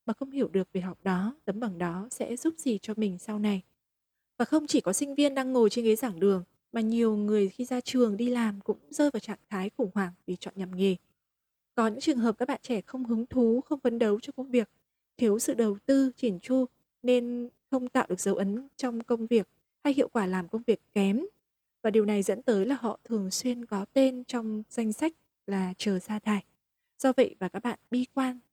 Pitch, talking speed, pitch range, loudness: 230 Hz, 235 wpm, 200-250 Hz, -29 LUFS